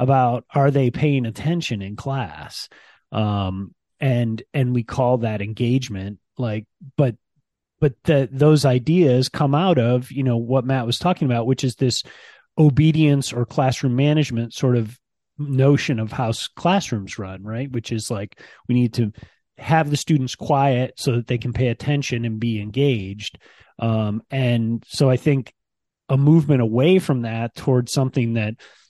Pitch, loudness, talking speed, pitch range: 125 Hz, -20 LUFS, 160 wpm, 115-140 Hz